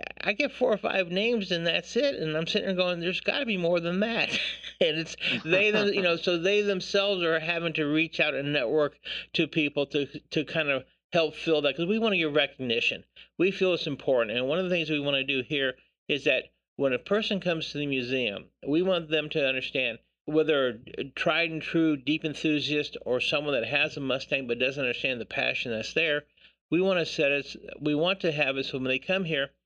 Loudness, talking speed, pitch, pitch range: -27 LUFS, 235 wpm, 160 Hz, 145-185 Hz